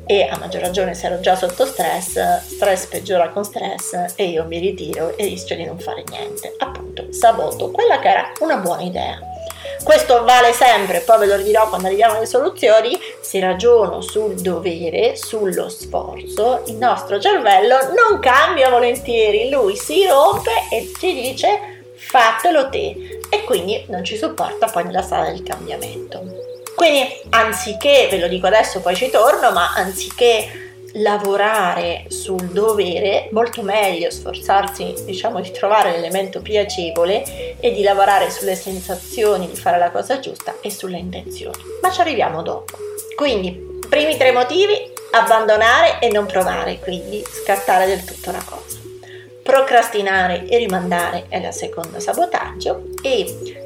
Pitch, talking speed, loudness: 230 Hz, 150 wpm, -17 LUFS